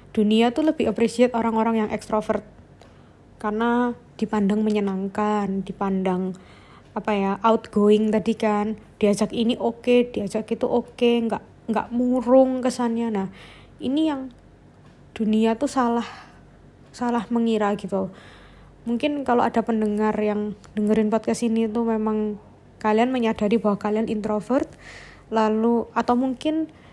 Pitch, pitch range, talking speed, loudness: 225 Hz, 210-240 Hz, 125 wpm, -23 LUFS